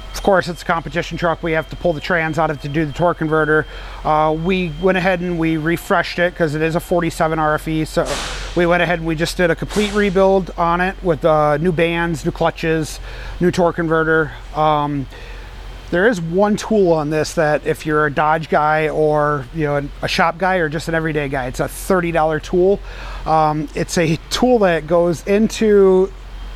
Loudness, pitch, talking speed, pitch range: -17 LUFS, 165 Hz, 210 wpm, 155-175 Hz